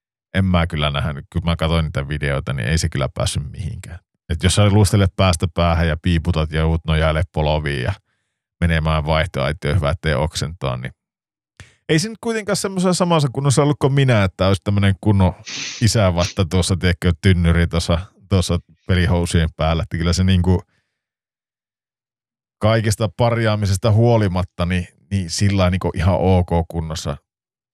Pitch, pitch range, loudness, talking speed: 90 Hz, 85-105 Hz, -19 LUFS, 145 wpm